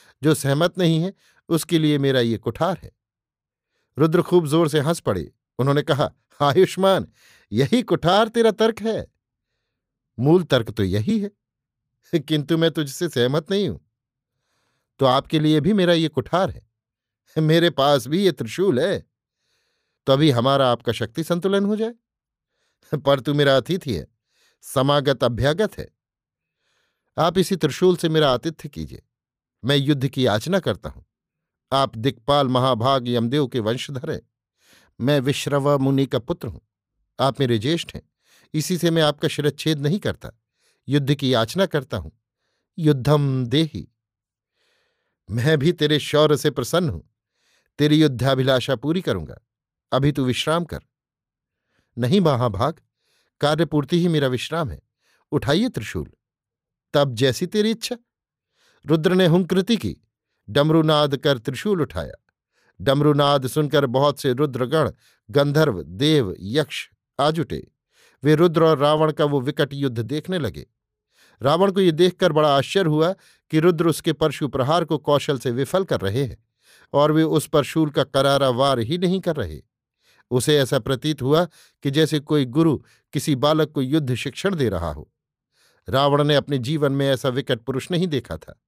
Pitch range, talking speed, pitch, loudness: 130-165 Hz, 150 wpm, 145 Hz, -21 LUFS